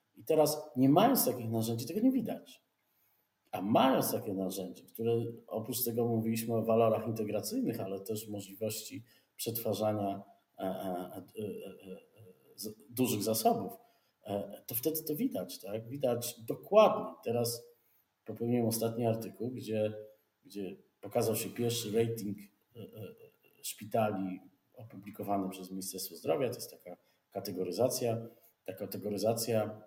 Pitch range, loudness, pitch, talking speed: 105-120 Hz, -34 LUFS, 115 Hz, 110 wpm